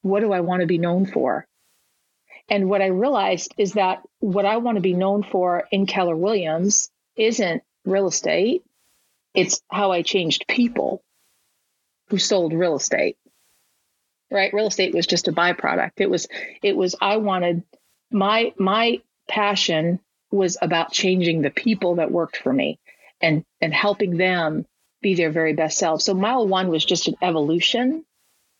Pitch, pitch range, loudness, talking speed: 190 Hz, 175-205 Hz, -21 LUFS, 160 wpm